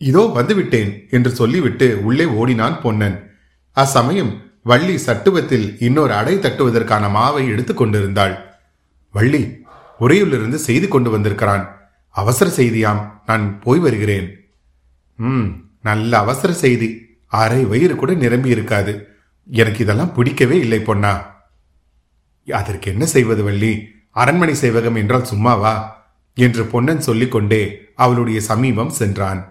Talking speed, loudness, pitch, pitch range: 110 wpm, -16 LUFS, 110 Hz, 100-125 Hz